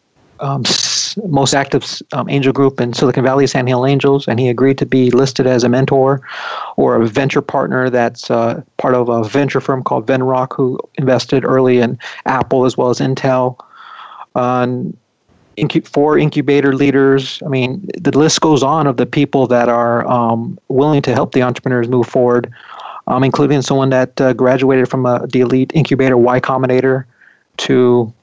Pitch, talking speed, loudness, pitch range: 130 Hz, 175 wpm, -14 LUFS, 125-140 Hz